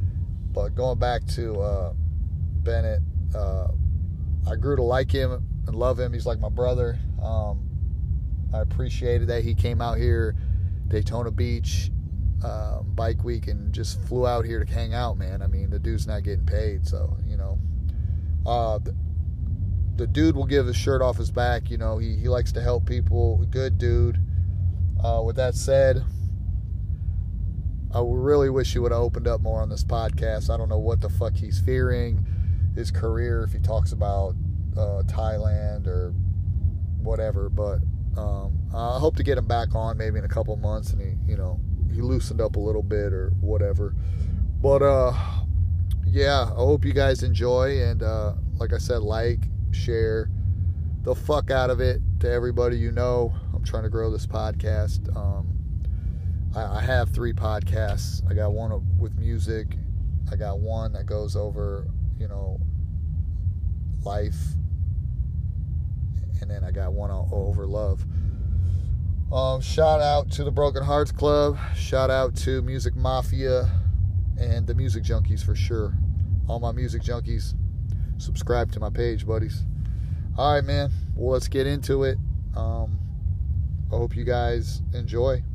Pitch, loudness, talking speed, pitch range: 90 Hz, -25 LUFS, 160 wpm, 85-100 Hz